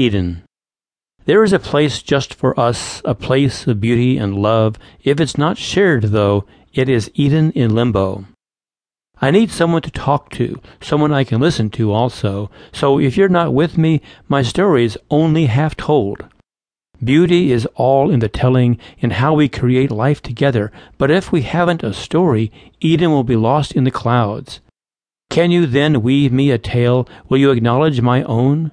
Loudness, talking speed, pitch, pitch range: -15 LUFS, 180 wpm, 130 Hz, 115-150 Hz